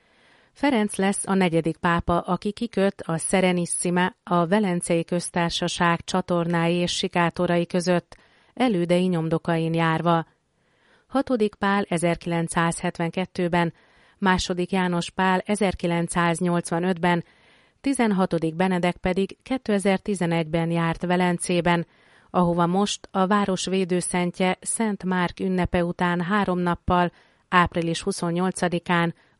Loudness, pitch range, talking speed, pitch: -23 LUFS, 170-190 Hz, 90 wpm, 180 Hz